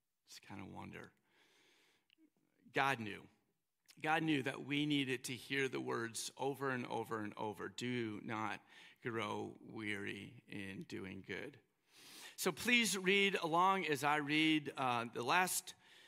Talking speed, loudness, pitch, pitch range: 140 wpm, -38 LUFS, 150 Hz, 130-190 Hz